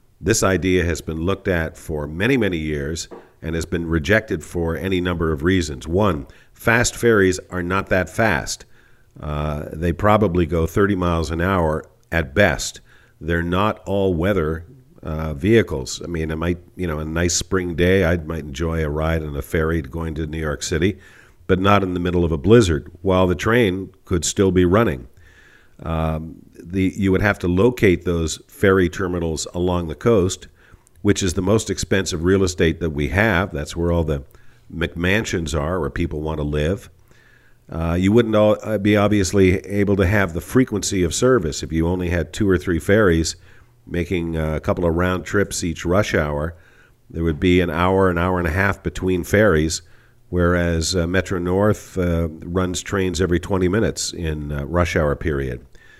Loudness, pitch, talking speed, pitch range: -20 LUFS, 90 Hz, 185 wpm, 80-100 Hz